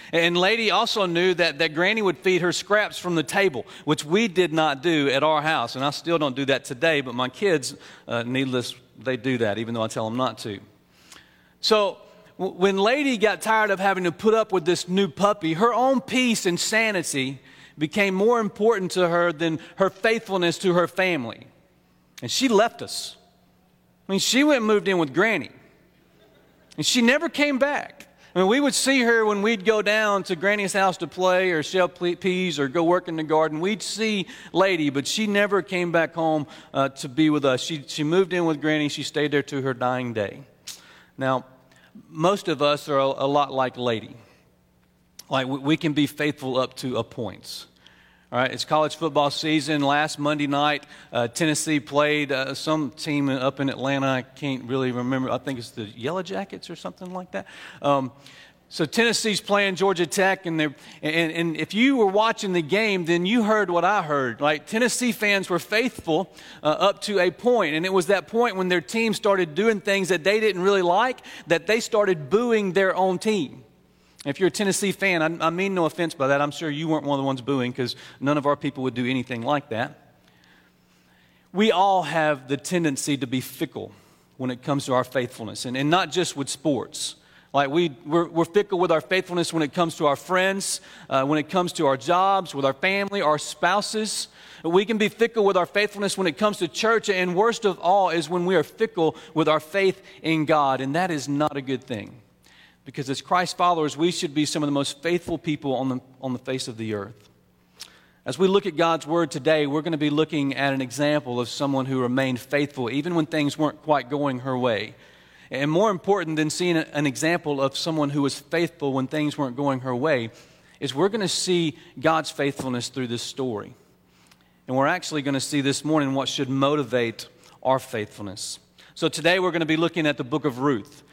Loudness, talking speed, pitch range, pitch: -23 LUFS, 210 wpm, 135-190 Hz, 155 Hz